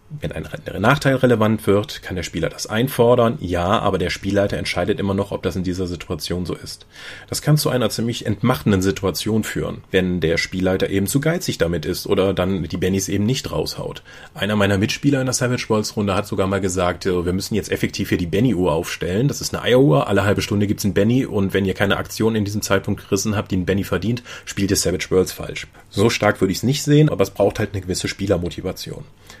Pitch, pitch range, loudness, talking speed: 100 Hz, 95-115 Hz, -20 LUFS, 225 wpm